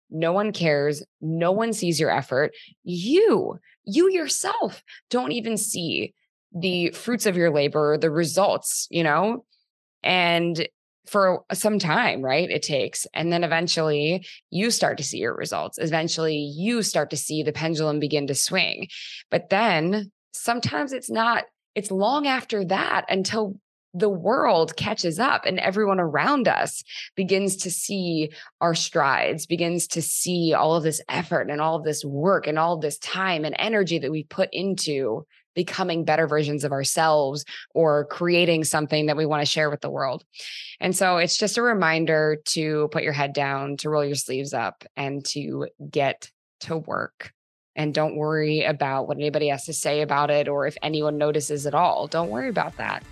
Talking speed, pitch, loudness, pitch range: 175 wpm, 165 Hz, -23 LUFS, 150-190 Hz